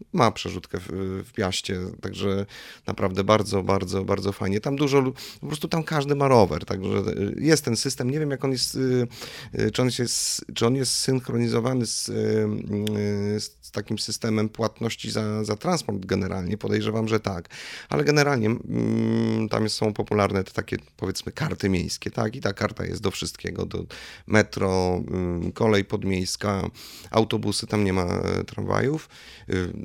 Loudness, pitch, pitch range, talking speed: -25 LUFS, 110 Hz, 100-120 Hz, 145 wpm